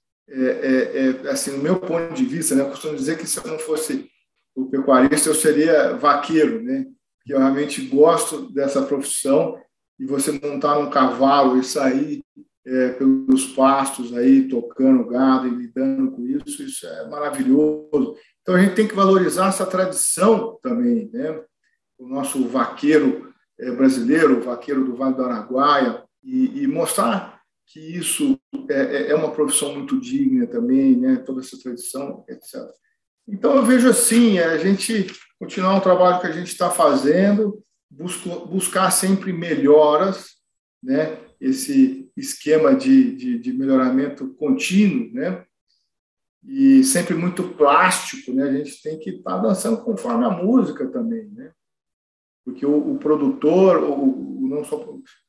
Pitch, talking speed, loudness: 185 Hz, 155 wpm, -19 LUFS